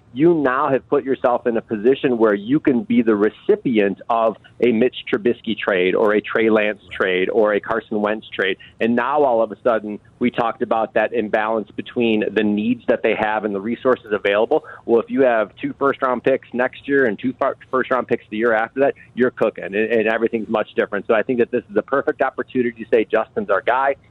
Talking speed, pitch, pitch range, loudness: 220 wpm, 115 Hz, 110-130 Hz, -19 LUFS